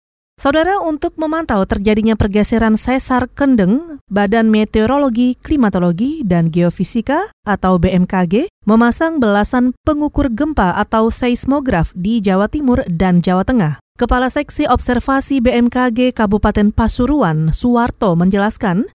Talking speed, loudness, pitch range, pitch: 110 wpm, -14 LUFS, 205-270 Hz, 235 Hz